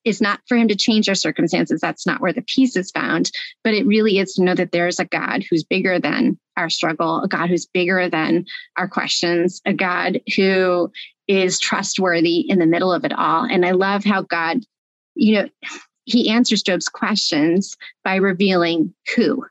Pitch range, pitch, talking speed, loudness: 175-215 Hz, 190 Hz, 190 wpm, -18 LUFS